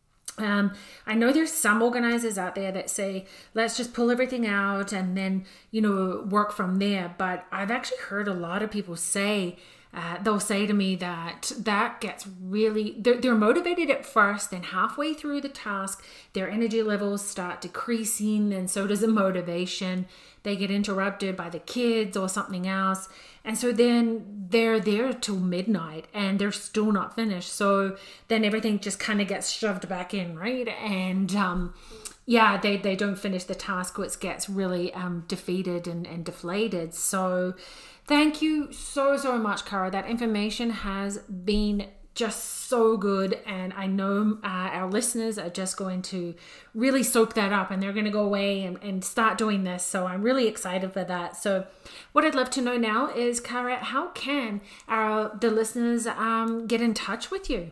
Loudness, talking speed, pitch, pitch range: -27 LUFS, 180 wpm, 205 Hz, 190-225 Hz